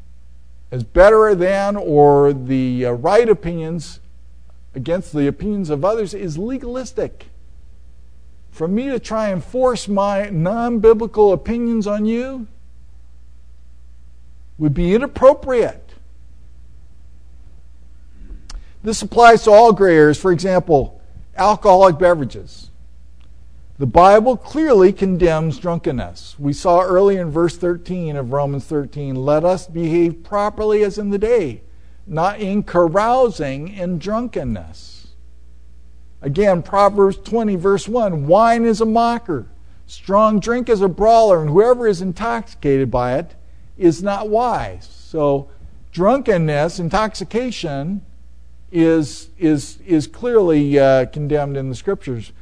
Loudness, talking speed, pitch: -16 LUFS, 115 wpm, 165 Hz